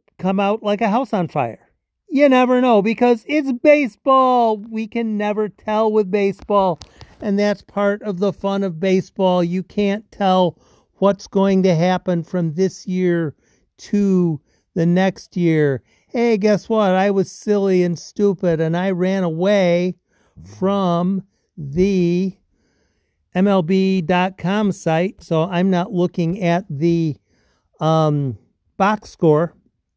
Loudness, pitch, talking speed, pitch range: -18 LUFS, 190 Hz, 130 wpm, 175-210 Hz